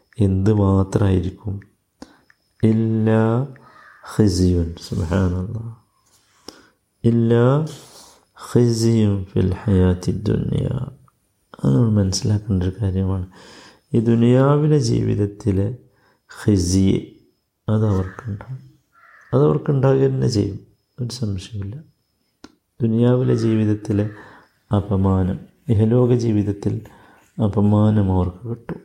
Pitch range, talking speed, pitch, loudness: 95-115 Hz, 60 wpm, 105 Hz, -19 LUFS